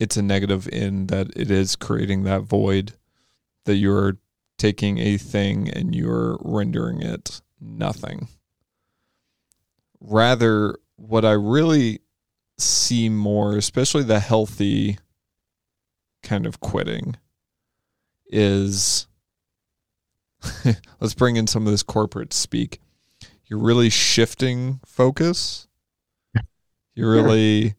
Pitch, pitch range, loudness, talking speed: 105 Hz, 100-115 Hz, -21 LUFS, 100 wpm